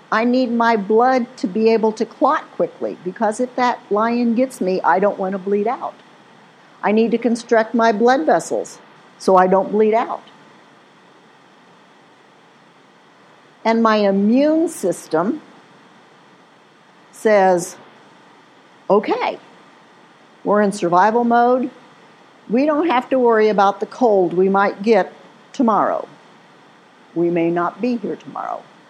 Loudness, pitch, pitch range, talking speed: -17 LUFS, 225 Hz, 200-245 Hz, 130 wpm